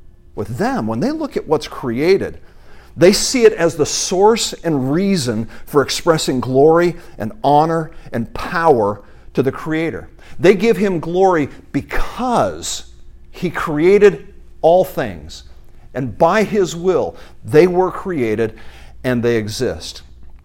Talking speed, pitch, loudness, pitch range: 130 wpm, 160 Hz, -16 LUFS, 115-185 Hz